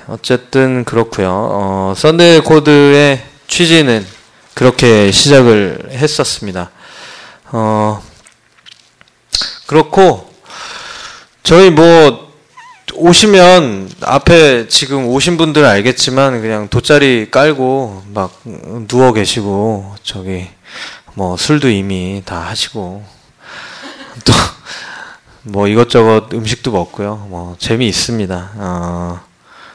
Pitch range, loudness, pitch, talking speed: 100-140 Hz, -10 LUFS, 115 Hz, 190 characters per minute